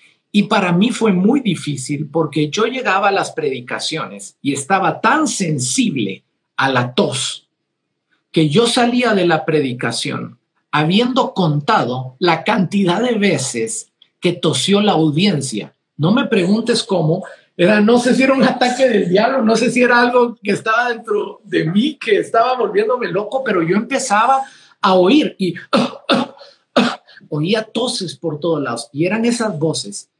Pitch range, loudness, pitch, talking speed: 160-245 Hz, -16 LUFS, 205 Hz, 155 wpm